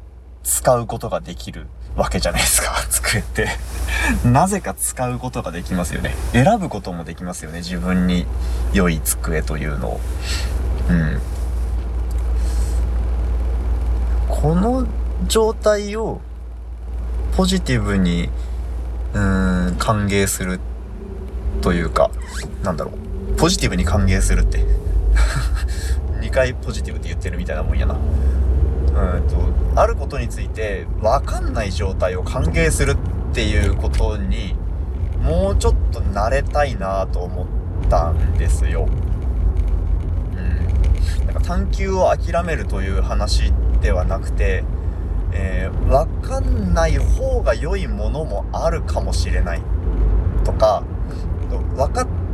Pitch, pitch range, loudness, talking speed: 85 Hz, 70-90 Hz, -20 LUFS, 240 characters per minute